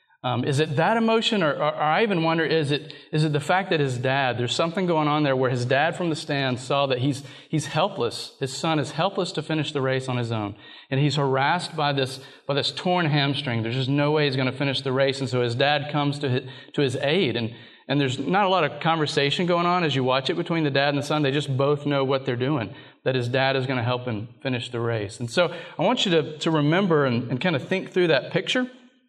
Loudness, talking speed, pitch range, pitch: -24 LUFS, 270 wpm, 135-160 Hz, 145 Hz